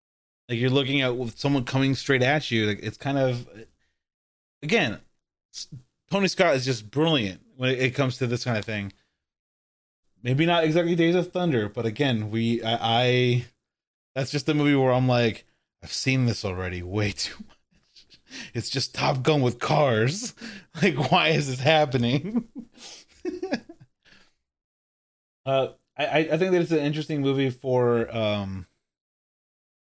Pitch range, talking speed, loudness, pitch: 115-155 Hz, 150 wpm, -24 LUFS, 130 Hz